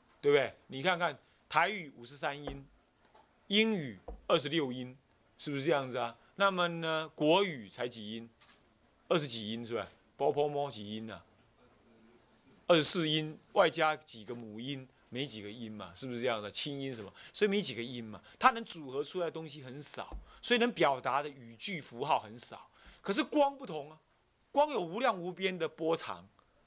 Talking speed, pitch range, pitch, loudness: 260 characters per minute, 115-165 Hz, 140 Hz, -34 LUFS